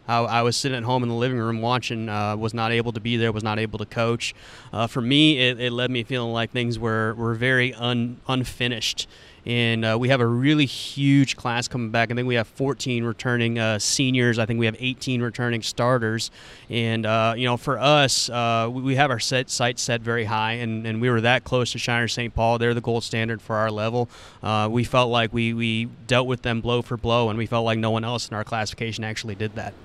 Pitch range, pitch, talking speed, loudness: 115-125 Hz, 115 Hz, 240 wpm, -23 LUFS